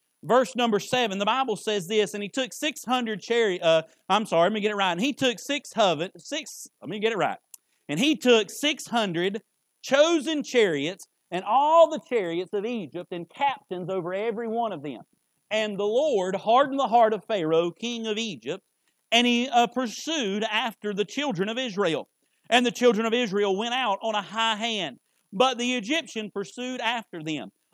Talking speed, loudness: 190 wpm, -25 LUFS